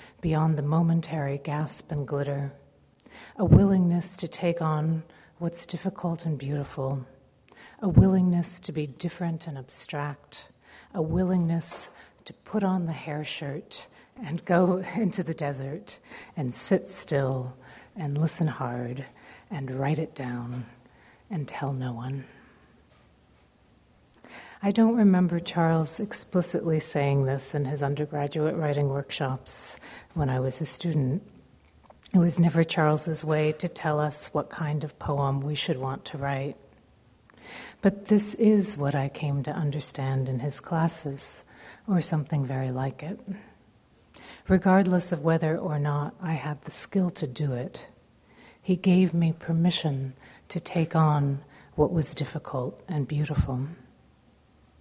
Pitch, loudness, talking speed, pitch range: 155 Hz, -27 LUFS, 135 wpm, 140-175 Hz